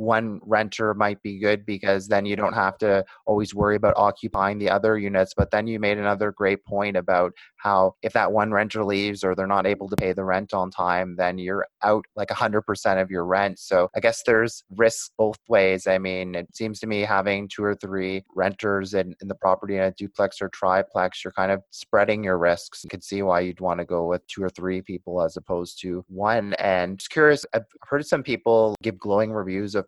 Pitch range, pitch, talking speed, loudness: 95-105 Hz, 100 Hz, 225 wpm, -23 LUFS